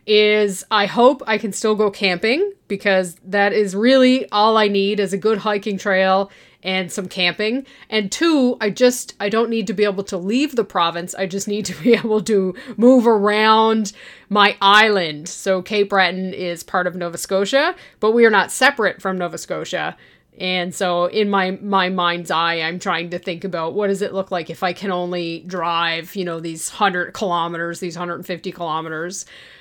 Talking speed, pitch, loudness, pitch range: 190 wpm, 195 Hz, -18 LUFS, 180-215 Hz